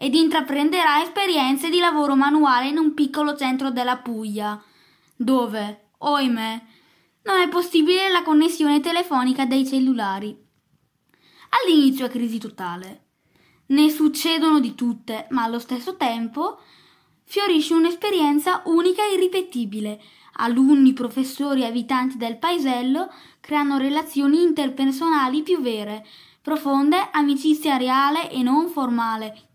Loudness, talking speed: -20 LUFS, 110 wpm